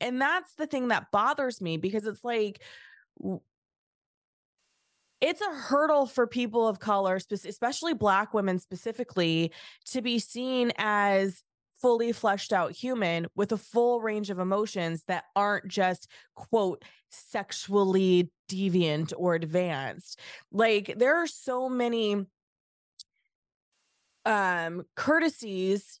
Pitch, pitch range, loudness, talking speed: 210 Hz, 185-240 Hz, -28 LUFS, 115 wpm